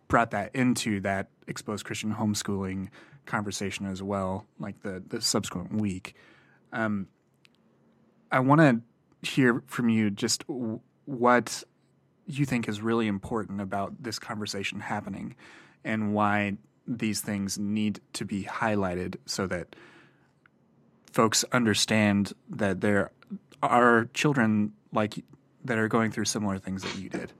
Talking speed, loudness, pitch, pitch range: 130 wpm, -28 LUFS, 110 Hz, 100-120 Hz